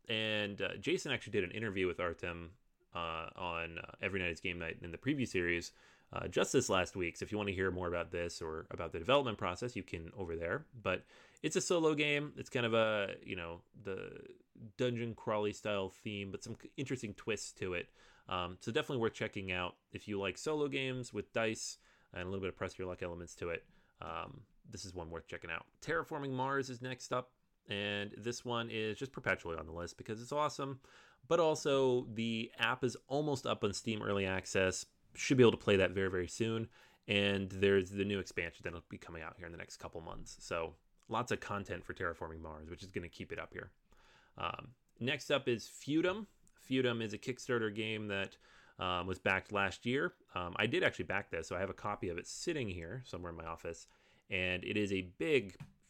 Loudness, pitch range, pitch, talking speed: -38 LUFS, 90-125 Hz, 100 Hz, 220 wpm